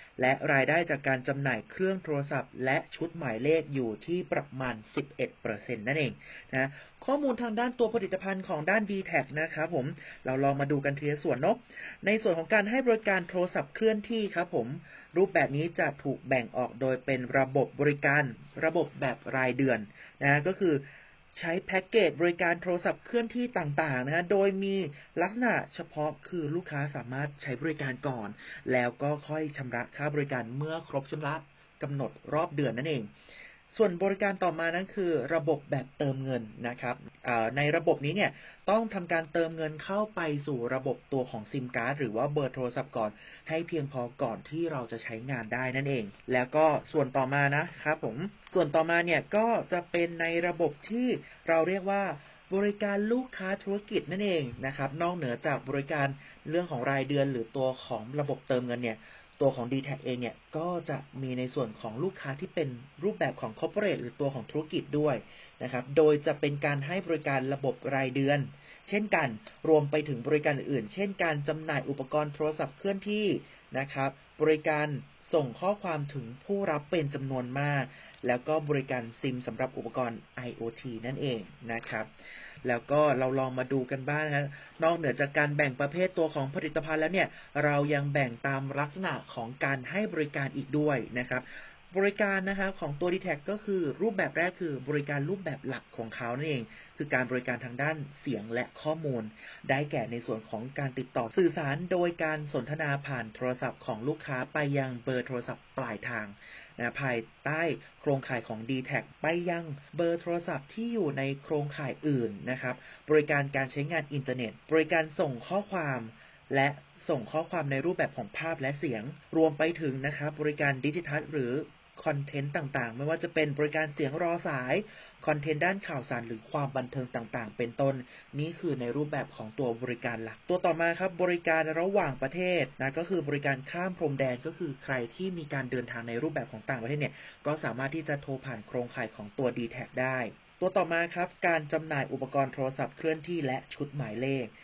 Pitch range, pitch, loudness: 130-165 Hz, 145 Hz, -31 LUFS